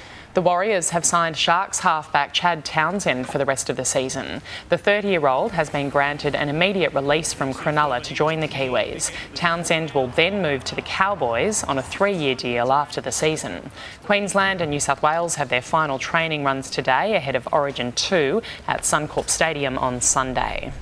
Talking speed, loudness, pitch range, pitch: 185 wpm, -21 LUFS, 135-170 Hz, 150 Hz